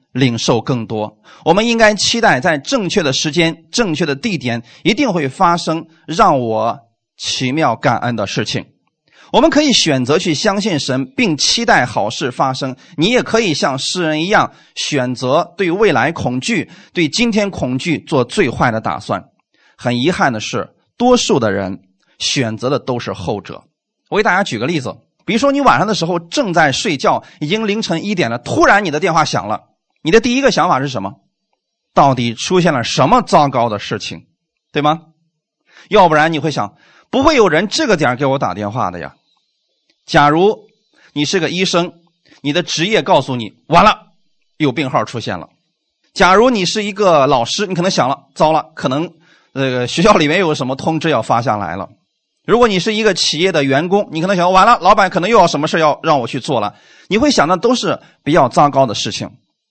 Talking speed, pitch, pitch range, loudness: 275 characters per minute, 160 Hz, 135-200 Hz, -14 LUFS